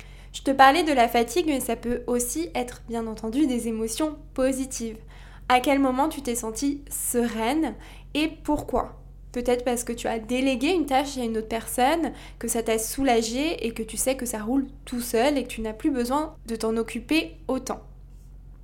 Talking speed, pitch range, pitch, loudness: 195 wpm, 230-275 Hz, 245 Hz, -25 LUFS